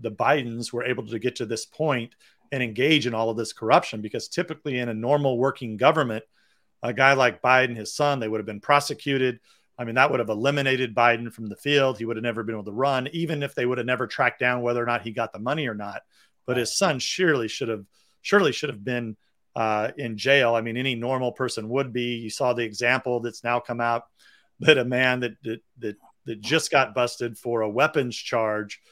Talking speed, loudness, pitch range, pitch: 230 wpm, -24 LUFS, 115-135 Hz, 120 Hz